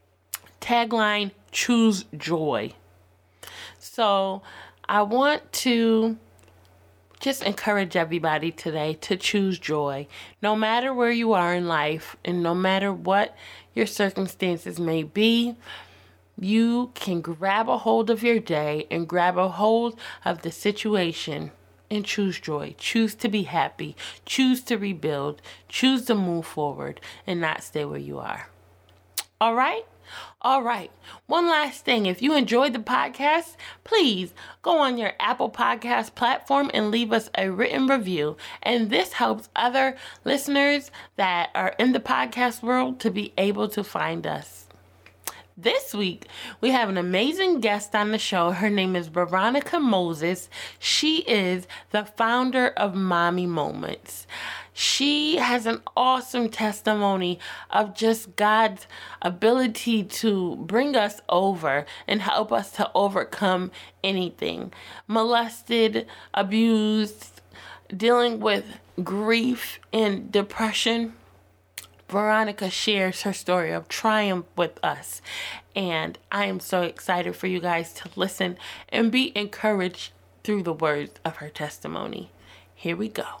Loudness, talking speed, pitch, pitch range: -24 LUFS, 130 wpm, 205 Hz, 175-235 Hz